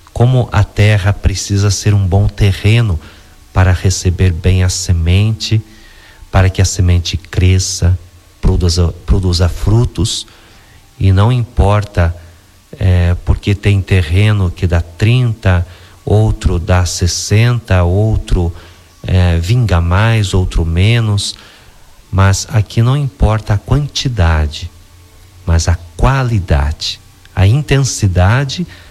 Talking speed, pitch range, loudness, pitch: 105 wpm, 90-105 Hz, -13 LUFS, 95 Hz